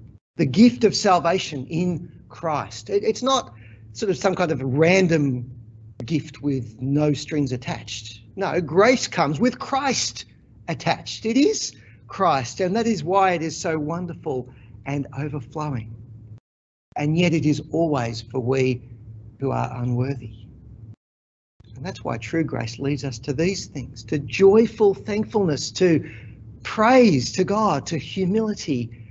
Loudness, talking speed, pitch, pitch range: -22 LUFS, 140 wpm, 145 Hz, 120-185 Hz